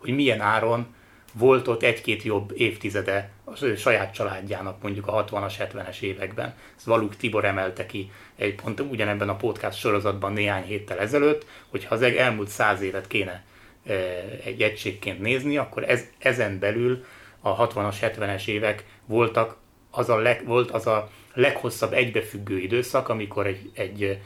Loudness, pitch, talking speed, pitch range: -25 LUFS, 105 Hz, 150 wpm, 100-115 Hz